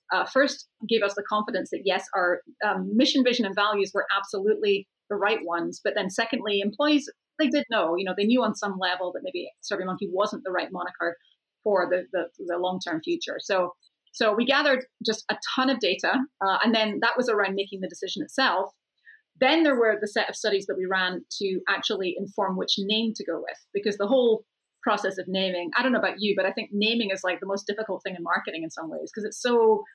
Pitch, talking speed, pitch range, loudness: 205 Hz, 220 wpm, 190-235 Hz, -26 LUFS